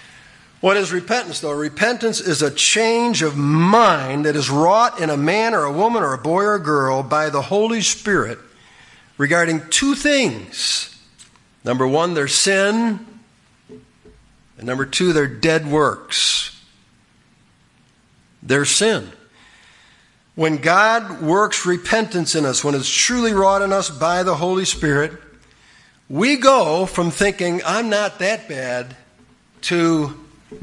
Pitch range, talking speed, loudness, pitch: 145-210 Hz, 135 wpm, -17 LUFS, 170 Hz